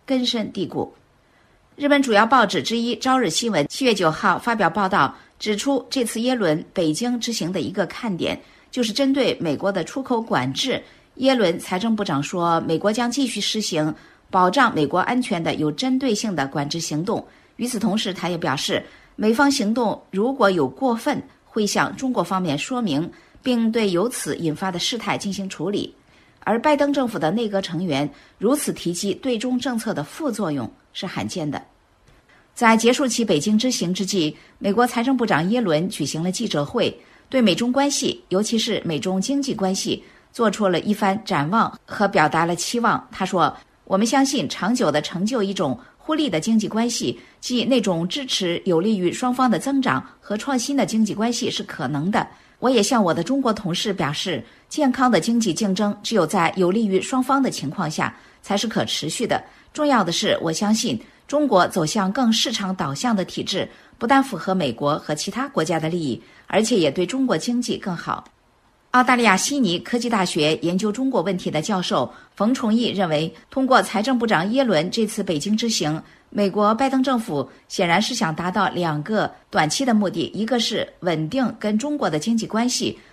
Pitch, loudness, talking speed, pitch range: 210 Hz, -21 LUFS, 280 characters per minute, 180-245 Hz